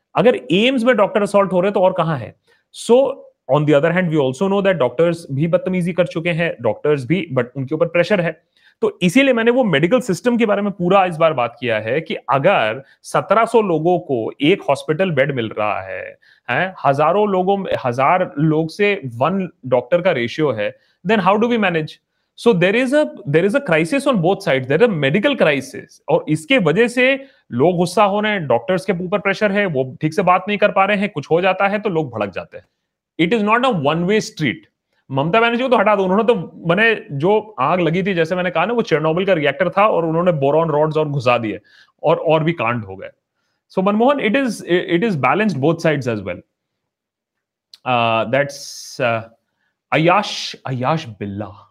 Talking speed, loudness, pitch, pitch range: 195 wpm, -17 LUFS, 180 Hz, 150-205 Hz